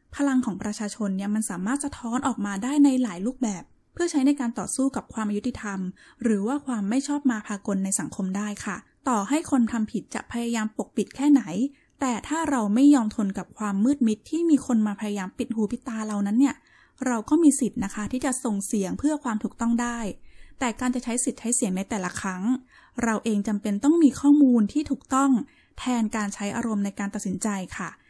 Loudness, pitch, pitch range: -25 LUFS, 230 Hz, 210-265 Hz